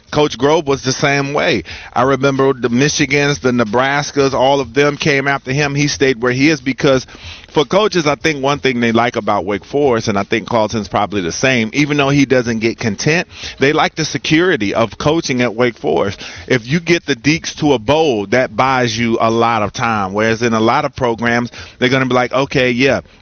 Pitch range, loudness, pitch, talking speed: 115-145 Hz, -14 LUFS, 130 Hz, 220 wpm